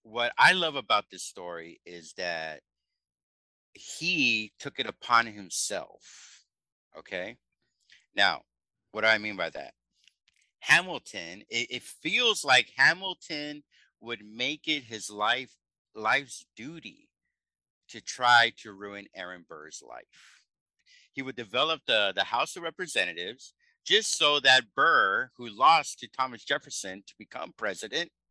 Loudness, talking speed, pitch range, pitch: -26 LUFS, 130 wpm, 100-140 Hz, 115 Hz